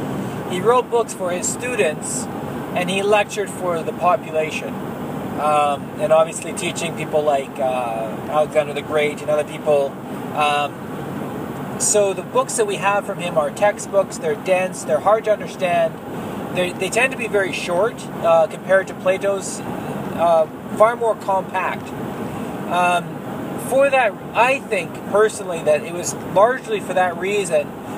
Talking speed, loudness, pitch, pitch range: 150 wpm, -20 LUFS, 185 Hz, 155-210 Hz